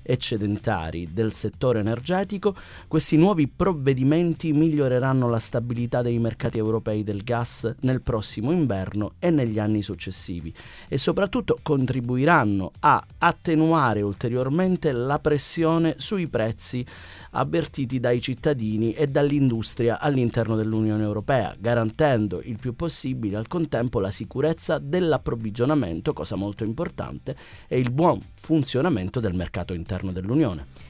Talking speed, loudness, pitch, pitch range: 115 wpm, -24 LUFS, 120 Hz, 110-155 Hz